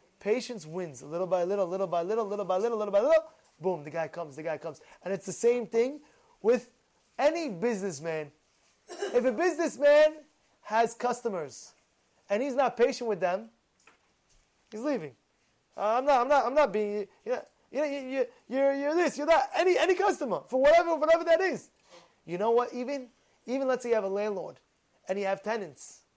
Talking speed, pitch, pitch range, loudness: 185 wpm, 240 Hz, 200-300 Hz, -29 LUFS